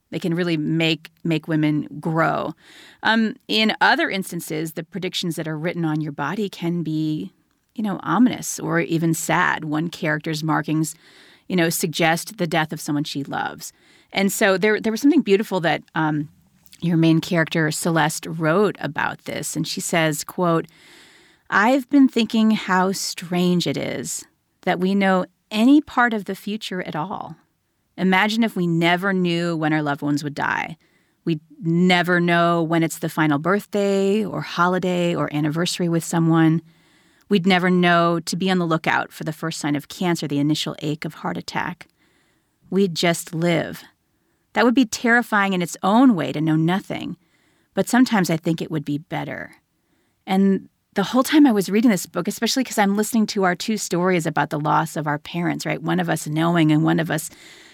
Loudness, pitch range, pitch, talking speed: -21 LUFS, 160-195 Hz, 175 Hz, 180 wpm